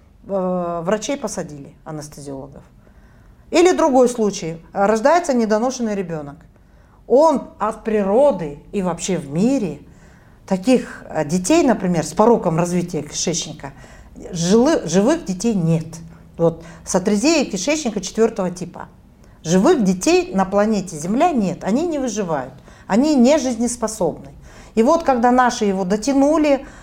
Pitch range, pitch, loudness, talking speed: 165-240 Hz, 195 Hz, -18 LUFS, 110 wpm